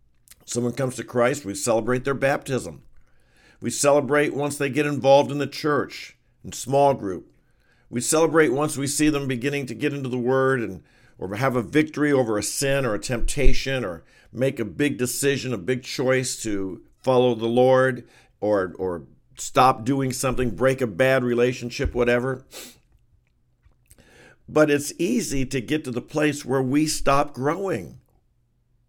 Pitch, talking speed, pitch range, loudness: 130 Hz, 160 wpm, 120-140 Hz, -23 LUFS